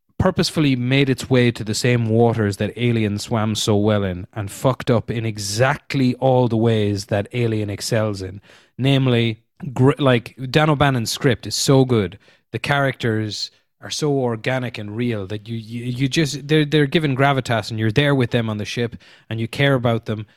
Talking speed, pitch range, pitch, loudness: 185 wpm, 110-135 Hz, 120 Hz, -19 LUFS